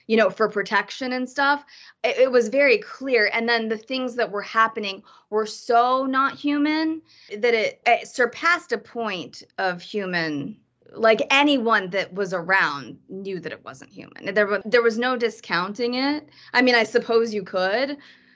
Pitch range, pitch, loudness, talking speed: 205-265 Hz, 235 Hz, -22 LUFS, 175 wpm